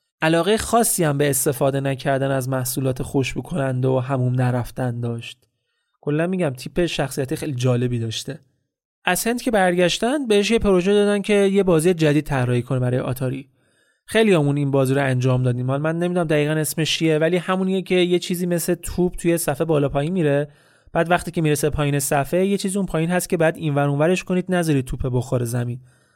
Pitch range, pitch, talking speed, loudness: 135-180 Hz, 150 Hz, 190 wpm, -20 LUFS